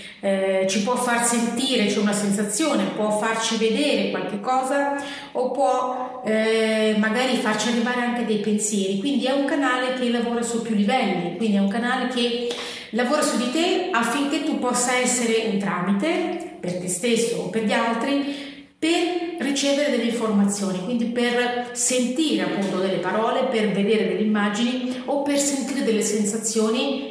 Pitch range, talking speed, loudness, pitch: 215-260 Hz, 160 wpm, -22 LUFS, 240 Hz